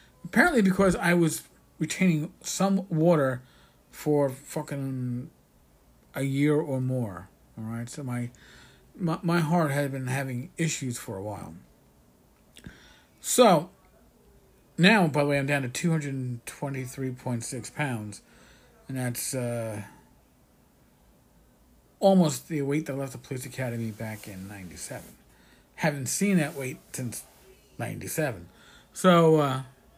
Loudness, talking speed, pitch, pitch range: -27 LUFS, 120 wpm, 135 Hz, 120-155 Hz